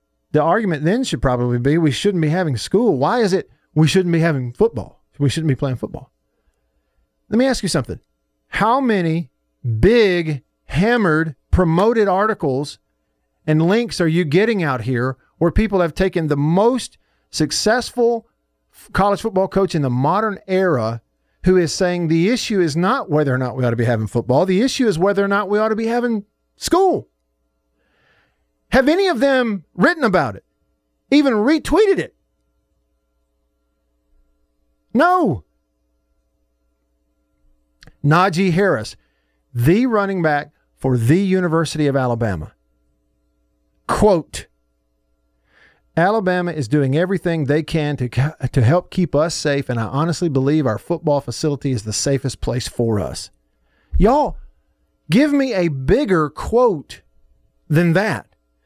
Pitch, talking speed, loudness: 145 Hz, 140 wpm, -18 LUFS